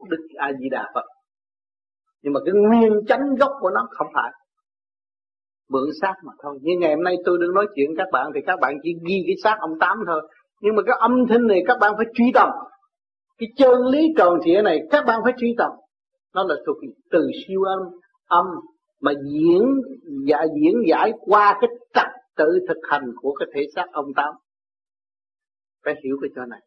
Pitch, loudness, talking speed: 210 Hz, -20 LUFS, 210 wpm